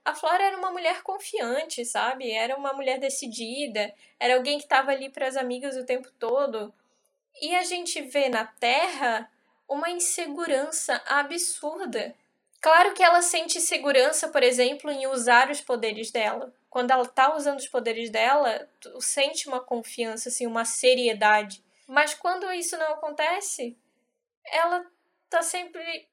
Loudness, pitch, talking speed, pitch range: -25 LUFS, 275 Hz, 150 wpm, 250-335 Hz